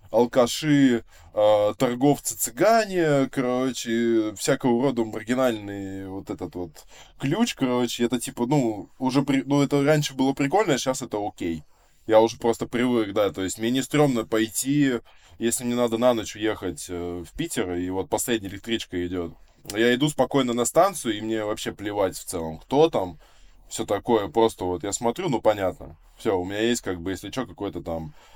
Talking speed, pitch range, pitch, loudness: 170 wpm, 100-130 Hz, 115 Hz, -24 LUFS